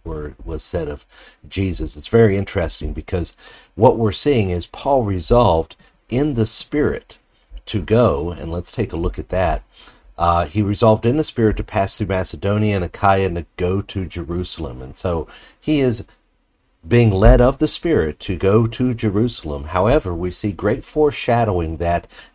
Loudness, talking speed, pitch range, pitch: -19 LUFS, 170 wpm, 85-115 Hz, 95 Hz